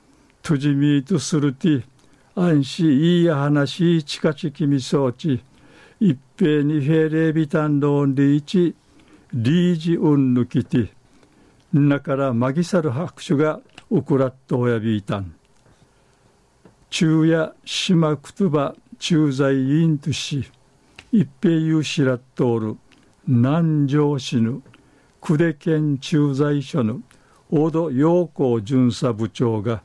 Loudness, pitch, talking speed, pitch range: -20 LUFS, 145 Hz, 265 characters per minute, 130-160 Hz